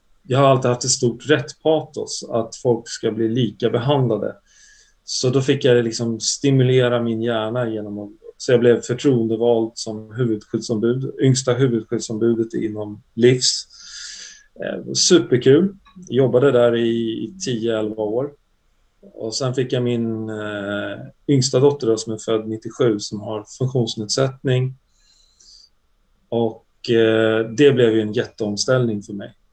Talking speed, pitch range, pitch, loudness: 125 wpm, 110-130 Hz, 115 Hz, -19 LUFS